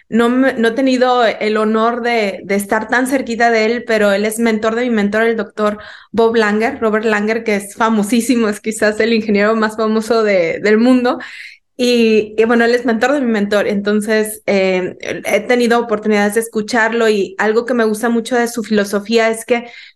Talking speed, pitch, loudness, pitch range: 195 wpm, 225 Hz, -14 LUFS, 210-235 Hz